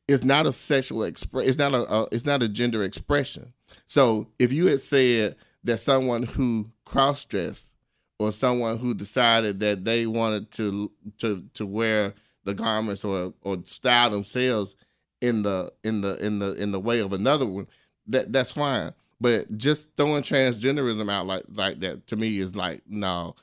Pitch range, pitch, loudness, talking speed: 105-130 Hz, 115 Hz, -24 LUFS, 175 wpm